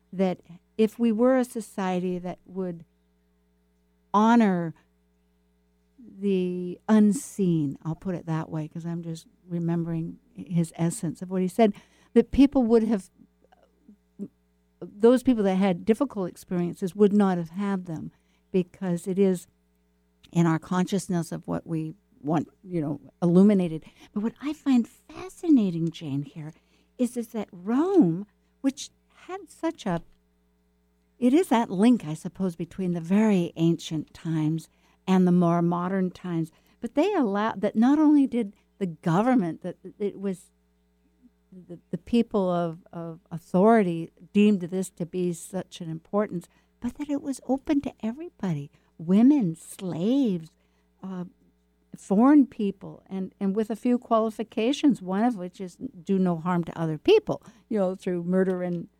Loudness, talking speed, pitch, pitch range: -25 LUFS, 145 wpm, 185 Hz, 165-220 Hz